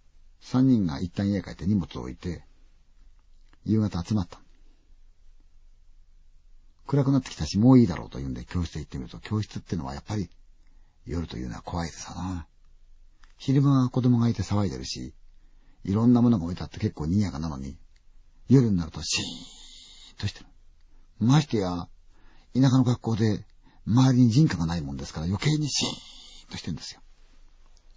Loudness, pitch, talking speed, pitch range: -26 LUFS, 85 Hz, 345 characters per minute, 75-105 Hz